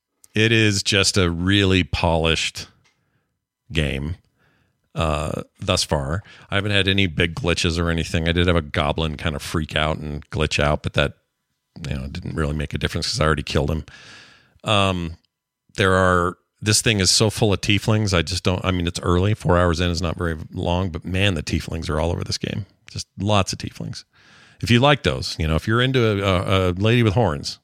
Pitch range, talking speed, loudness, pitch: 85-105 Hz, 205 wpm, -20 LUFS, 90 Hz